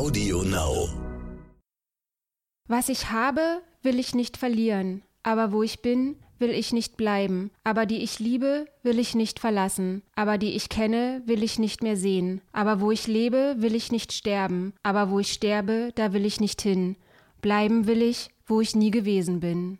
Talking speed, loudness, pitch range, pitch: 175 wpm, -26 LUFS, 195-235 Hz, 220 Hz